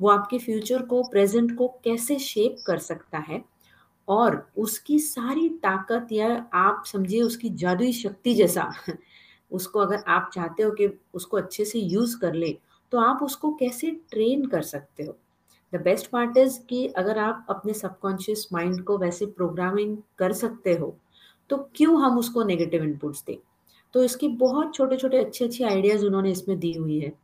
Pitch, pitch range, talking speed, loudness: 215 Hz, 185-245 Hz, 170 wpm, -25 LUFS